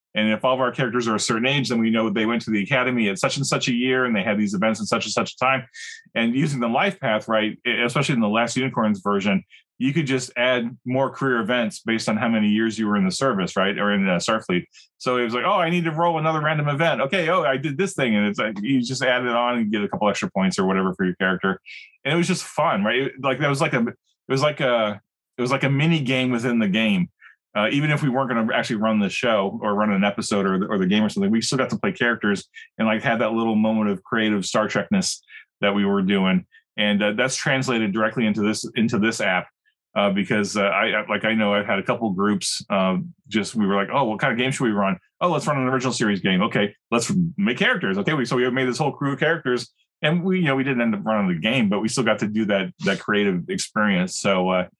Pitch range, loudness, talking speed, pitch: 105-140 Hz, -22 LUFS, 275 wpm, 120 Hz